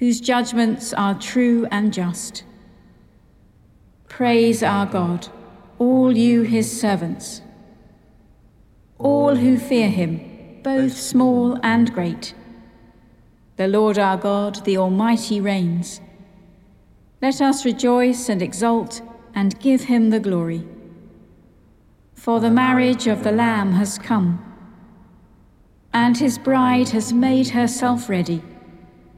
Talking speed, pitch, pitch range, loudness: 110 wpm, 220 Hz, 195-245 Hz, -19 LUFS